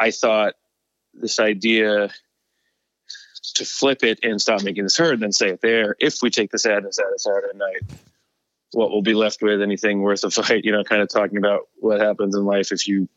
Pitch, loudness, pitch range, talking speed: 105 Hz, -20 LUFS, 100-135 Hz, 215 wpm